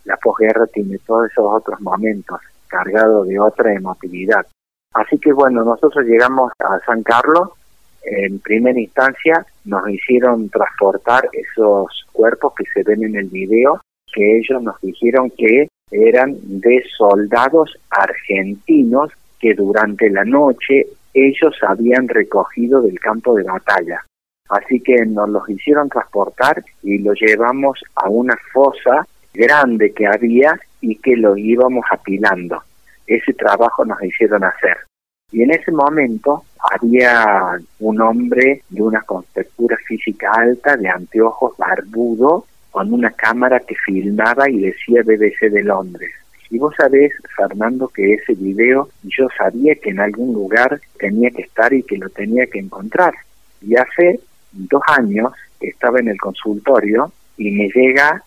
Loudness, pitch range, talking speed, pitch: -14 LUFS, 105-130 Hz, 140 wpm, 115 Hz